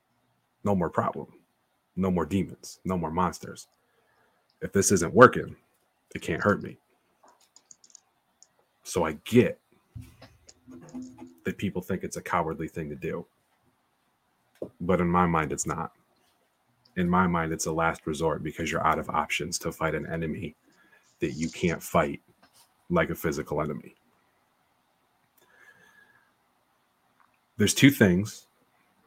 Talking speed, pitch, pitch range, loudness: 130 wpm, 90 Hz, 80-95 Hz, -27 LUFS